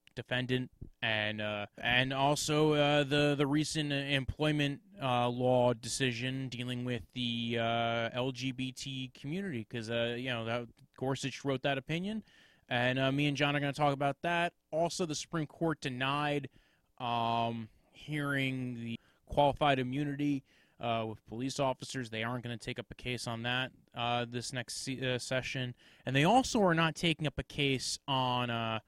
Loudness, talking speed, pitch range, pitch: -33 LUFS, 165 wpm, 120-145 Hz, 130 Hz